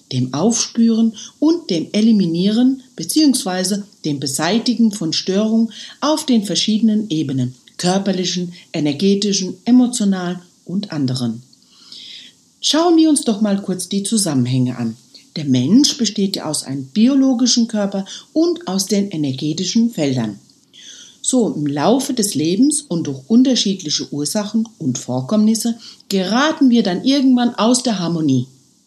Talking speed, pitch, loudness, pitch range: 125 wpm, 200 Hz, -17 LUFS, 155-235 Hz